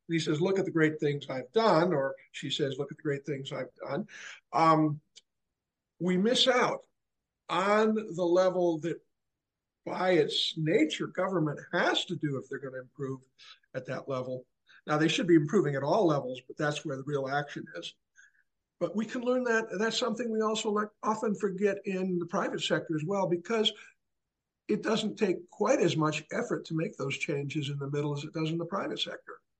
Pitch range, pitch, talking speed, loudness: 145-200 Hz, 165 Hz, 200 wpm, -30 LUFS